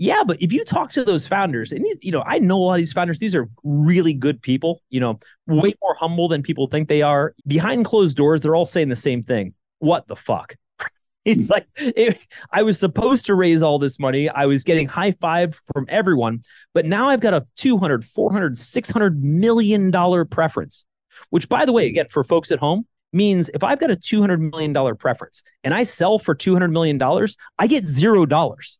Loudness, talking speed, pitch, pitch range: -19 LUFS, 215 wpm, 170 Hz, 145-200 Hz